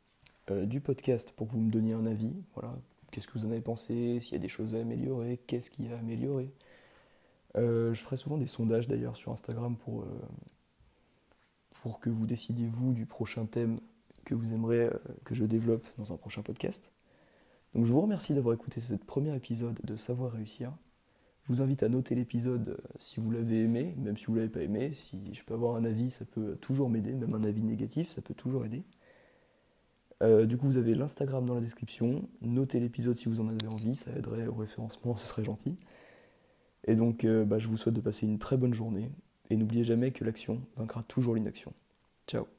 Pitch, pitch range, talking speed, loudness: 115 Hz, 110-130 Hz, 215 wpm, -33 LUFS